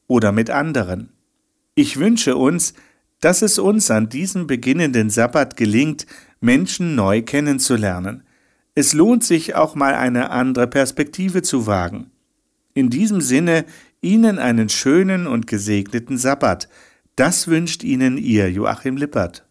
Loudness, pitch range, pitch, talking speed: -17 LUFS, 120-195 Hz, 145 Hz, 130 wpm